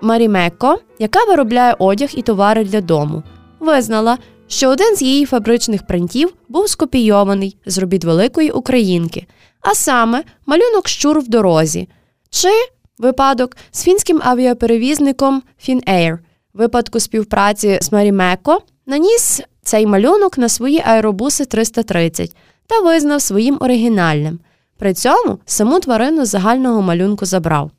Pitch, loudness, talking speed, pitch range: 235 Hz, -14 LUFS, 120 wpm, 195-280 Hz